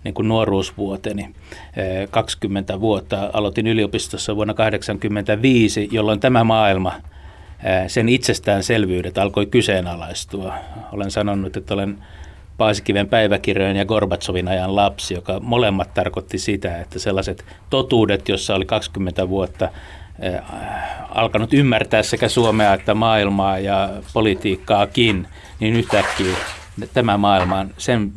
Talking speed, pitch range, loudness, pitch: 110 wpm, 95-110 Hz, -19 LUFS, 100 Hz